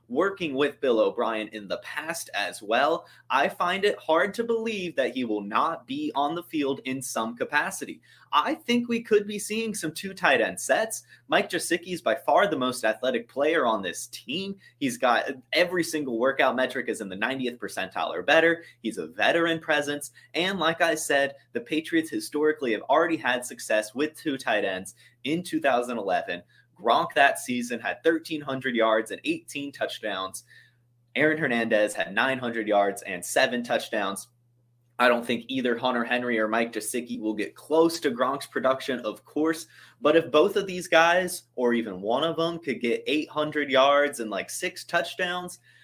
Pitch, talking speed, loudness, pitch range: 150 Hz, 180 wpm, -26 LUFS, 120-170 Hz